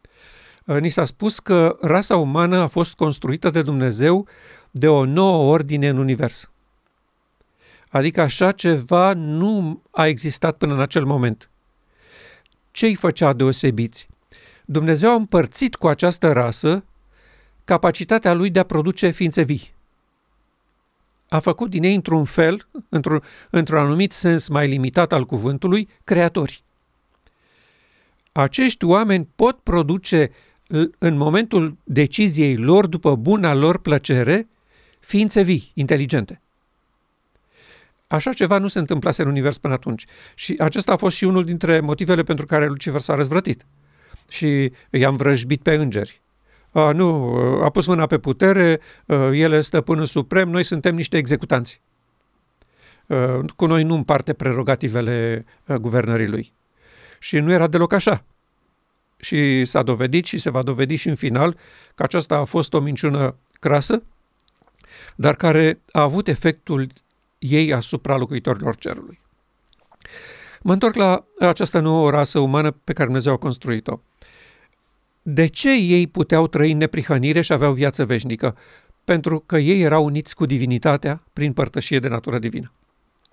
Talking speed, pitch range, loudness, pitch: 135 wpm, 140-175 Hz, -19 LUFS, 155 Hz